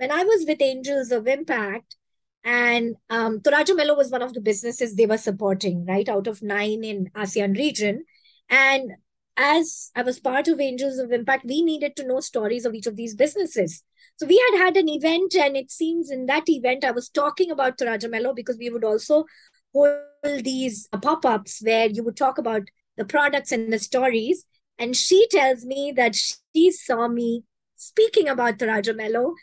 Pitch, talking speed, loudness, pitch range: 255 Hz, 180 wpm, -22 LUFS, 225-290 Hz